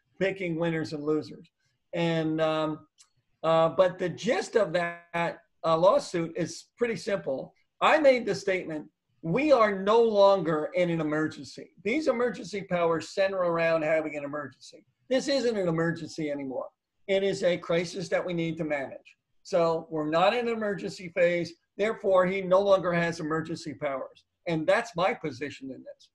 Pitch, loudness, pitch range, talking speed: 170 Hz, -27 LUFS, 155-195 Hz, 160 wpm